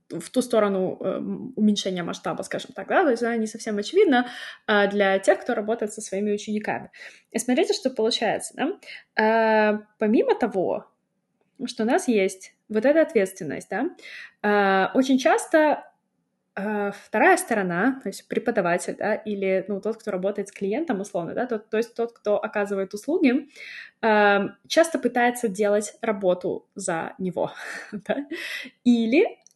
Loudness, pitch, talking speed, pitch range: -24 LUFS, 215 Hz, 140 wpm, 200-245 Hz